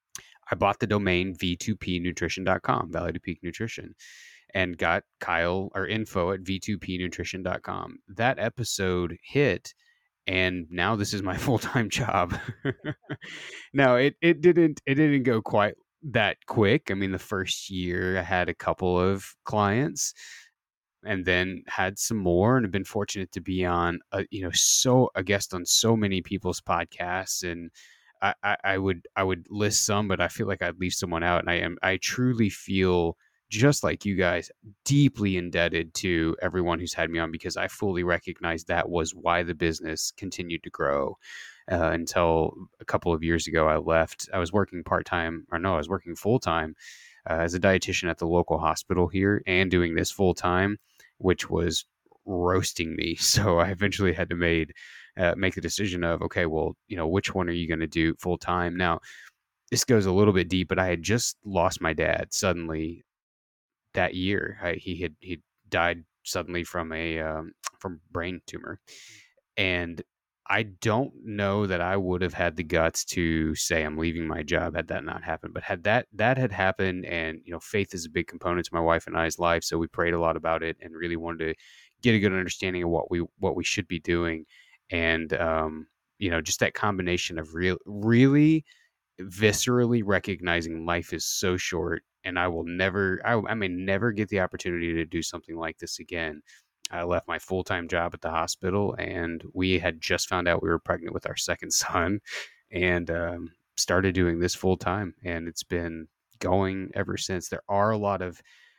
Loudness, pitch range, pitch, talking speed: -27 LUFS, 85-100 Hz, 90 Hz, 190 wpm